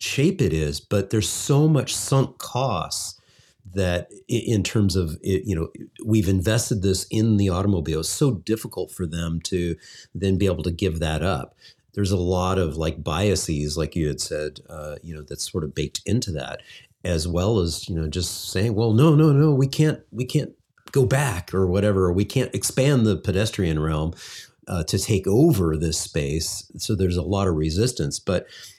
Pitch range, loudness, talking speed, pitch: 85-110 Hz, -23 LUFS, 195 wpm, 95 Hz